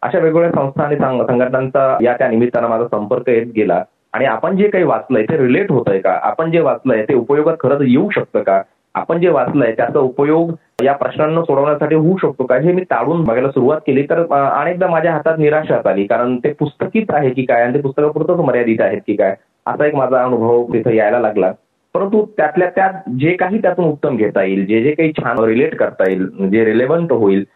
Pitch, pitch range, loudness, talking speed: 145 Hz, 120-165 Hz, -15 LUFS, 200 wpm